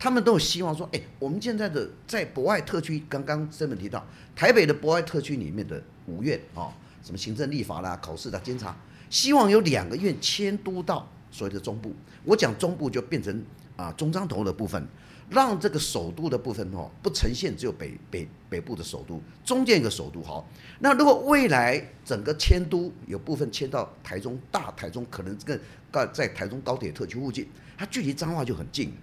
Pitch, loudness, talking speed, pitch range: 150 Hz, -27 LUFS, 305 characters per minute, 125-190 Hz